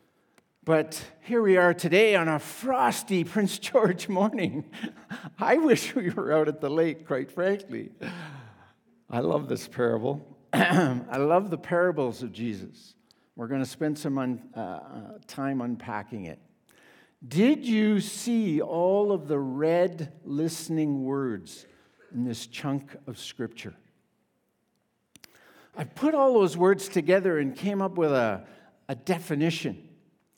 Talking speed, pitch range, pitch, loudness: 135 wpm, 140-195 Hz, 165 Hz, -26 LUFS